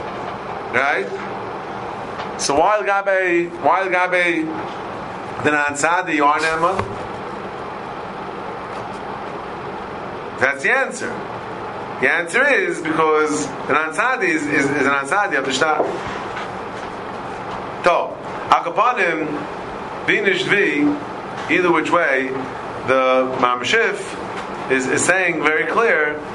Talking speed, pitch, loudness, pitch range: 90 wpm, 155 Hz, -19 LUFS, 145-180 Hz